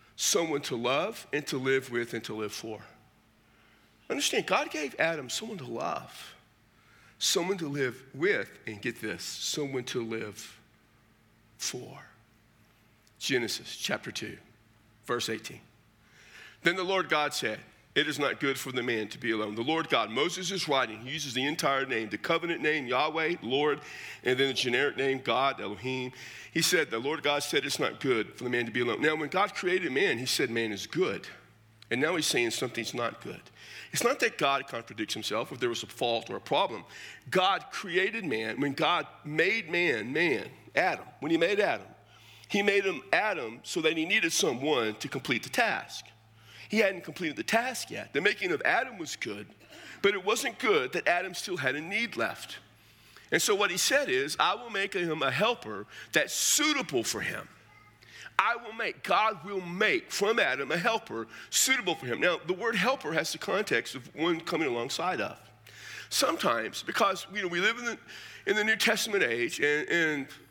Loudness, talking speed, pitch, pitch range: -29 LUFS, 190 wpm, 140 Hz, 115-190 Hz